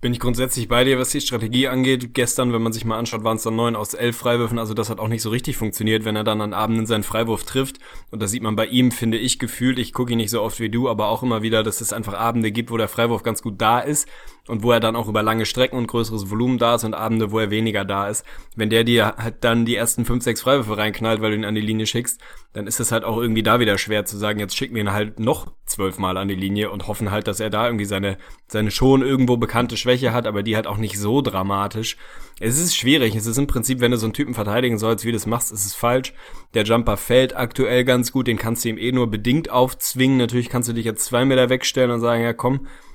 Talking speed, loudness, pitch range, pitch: 275 wpm, -20 LUFS, 110-125 Hz, 115 Hz